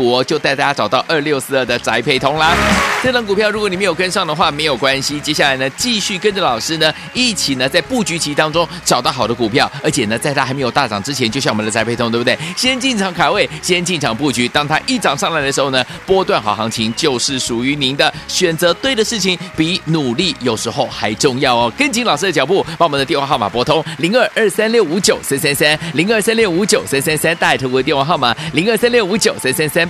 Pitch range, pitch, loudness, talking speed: 130-190 Hz, 155 Hz, -14 LUFS, 365 characters per minute